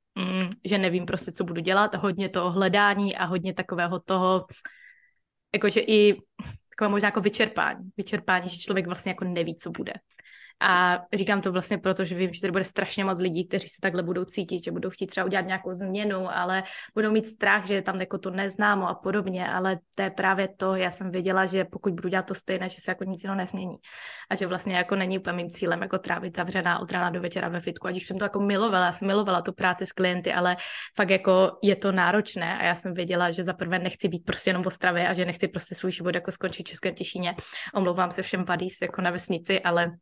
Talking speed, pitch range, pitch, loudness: 230 wpm, 180-195 Hz, 185 Hz, -26 LUFS